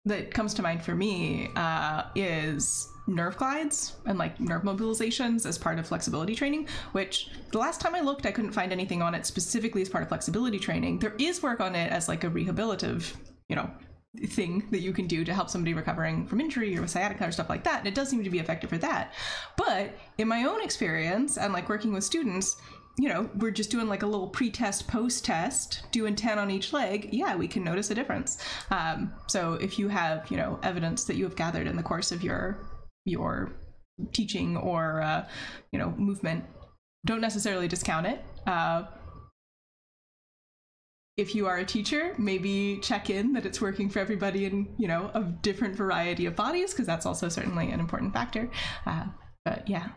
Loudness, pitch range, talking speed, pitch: -30 LUFS, 180-230 Hz, 200 wpm, 205 Hz